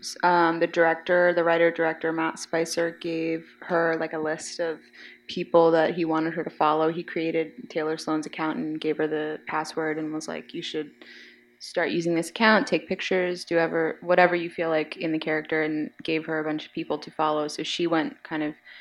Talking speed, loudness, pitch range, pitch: 215 wpm, -25 LUFS, 155-170 Hz, 160 Hz